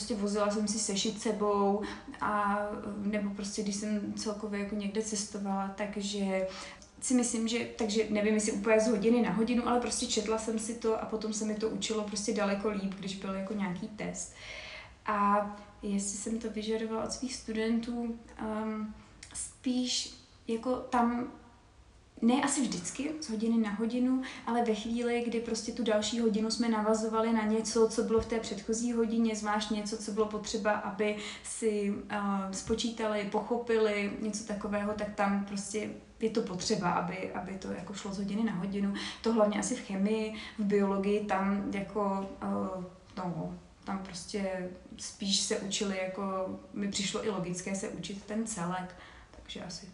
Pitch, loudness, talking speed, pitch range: 215 Hz, -33 LUFS, 165 wpm, 200-225 Hz